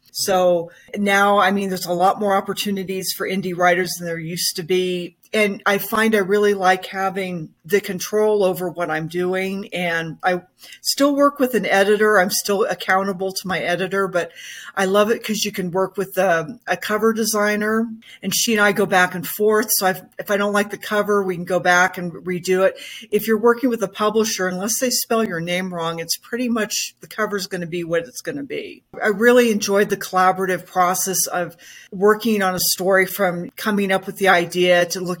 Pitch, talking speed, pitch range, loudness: 190 Hz, 210 wpm, 180-210 Hz, -19 LUFS